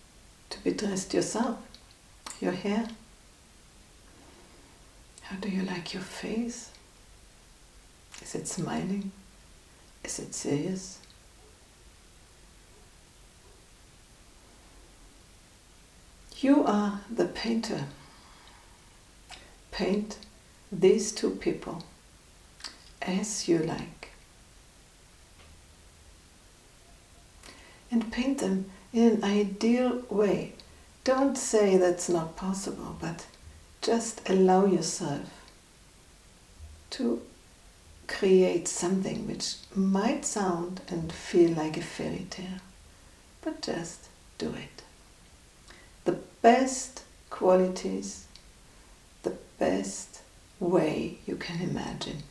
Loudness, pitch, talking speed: -29 LUFS, 185 Hz, 80 wpm